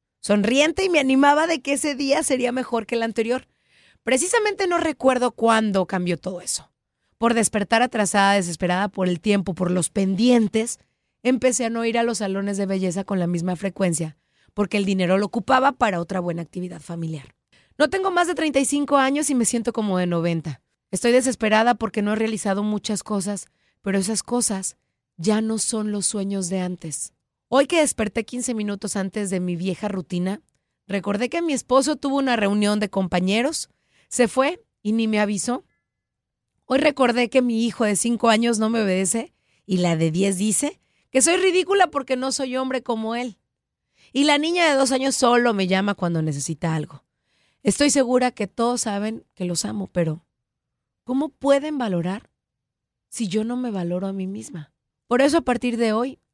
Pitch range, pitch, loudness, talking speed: 190-260 Hz, 220 Hz, -22 LUFS, 180 wpm